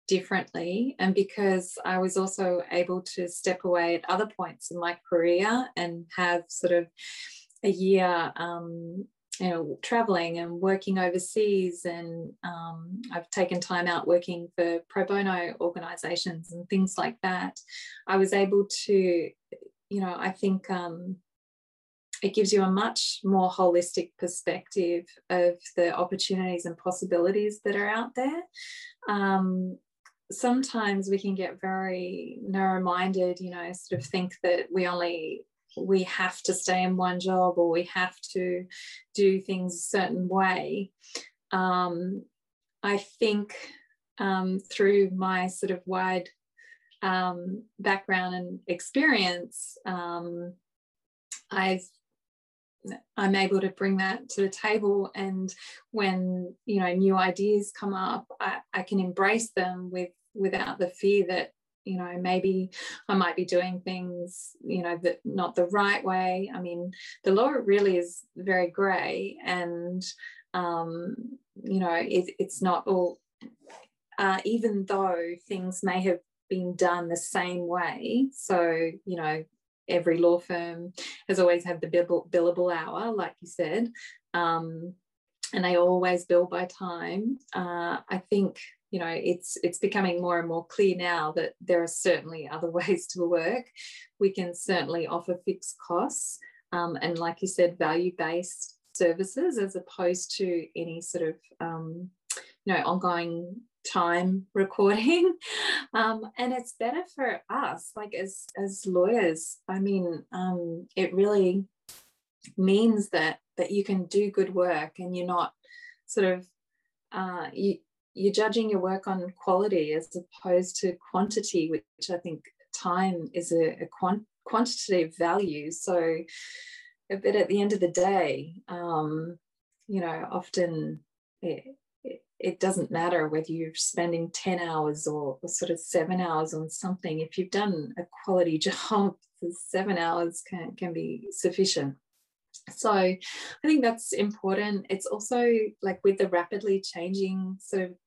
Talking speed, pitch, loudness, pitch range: 145 wpm, 185 Hz, -28 LUFS, 175-200 Hz